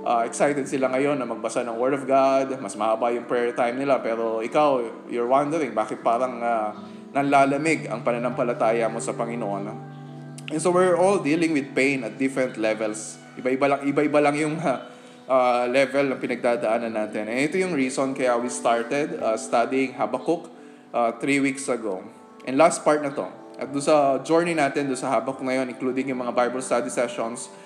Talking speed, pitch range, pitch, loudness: 180 wpm, 120-140 Hz, 130 Hz, -23 LUFS